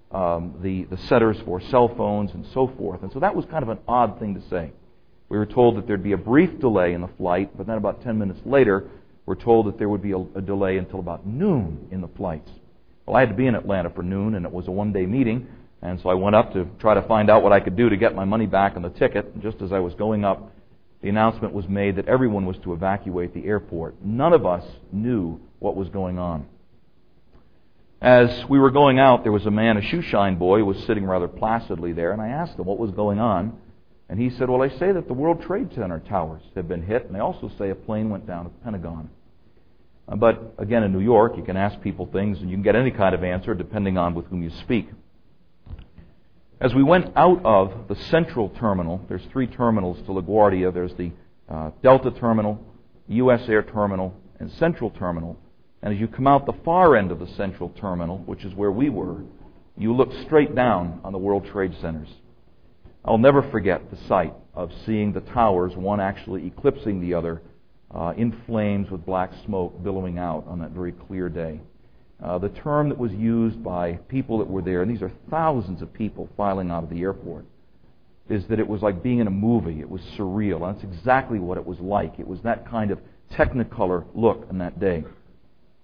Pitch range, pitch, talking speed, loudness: 90-115 Hz, 100 Hz, 225 wpm, -22 LUFS